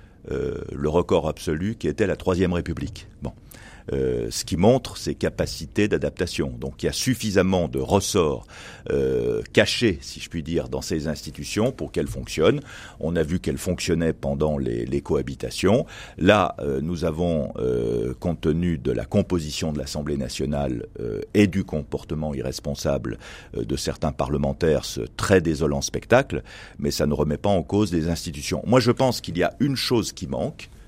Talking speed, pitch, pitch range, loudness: 175 wpm, 80 Hz, 75-95 Hz, -24 LUFS